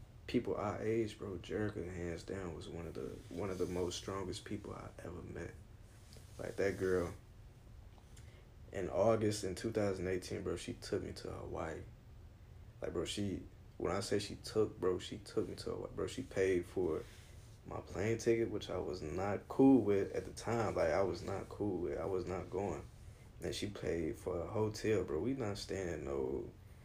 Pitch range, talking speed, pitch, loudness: 95-110 Hz, 190 wpm, 100 Hz, -39 LUFS